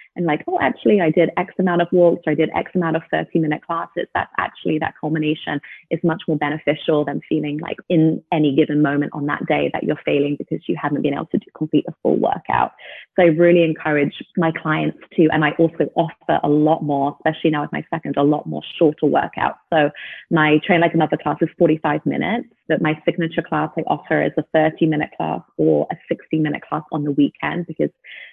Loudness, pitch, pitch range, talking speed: -19 LUFS, 155 Hz, 150-165 Hz, 220 wpm